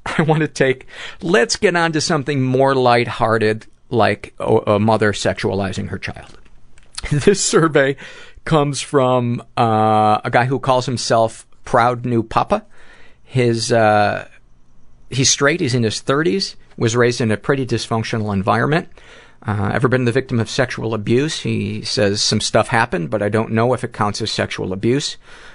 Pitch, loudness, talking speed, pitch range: 120 Hz, -17 LUFS, 160 wpm, 110-135 Hz